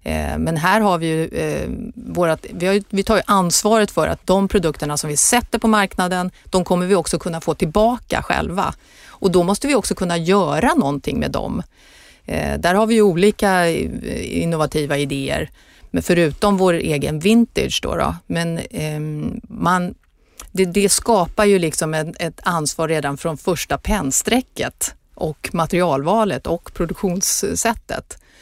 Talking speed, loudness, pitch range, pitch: 155 wpm, -19 LUFS, 155-205 Hz, 180 Hz